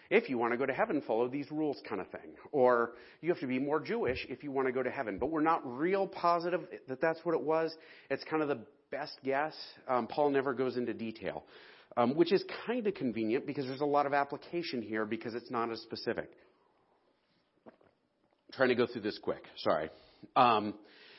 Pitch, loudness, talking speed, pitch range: 140 Hz, -33 LUFS, 215 wpm, 120-160 Hz